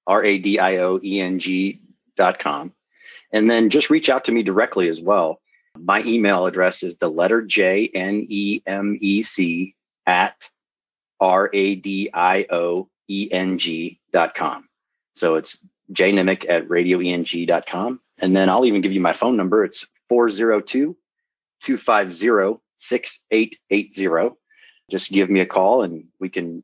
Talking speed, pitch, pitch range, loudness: 135 wpm, 100 Hz, 90-110 Hz, -19 LUFS